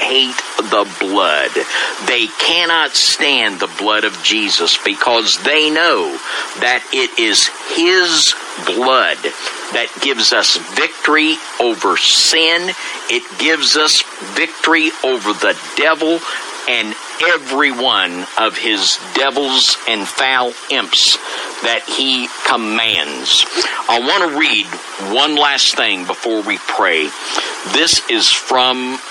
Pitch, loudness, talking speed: 155 Hz, -13 LUFS, 115 wpm